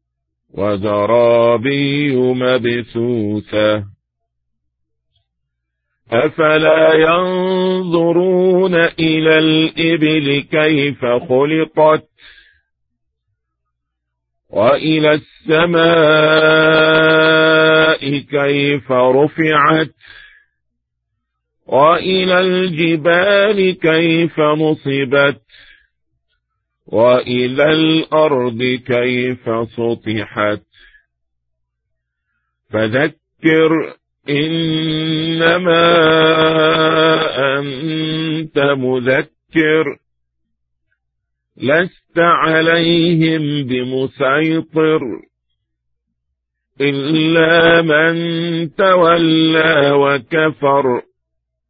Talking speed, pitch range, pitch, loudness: 35 wpm, 115-160 Hz, 145 Hz, -13 LUFS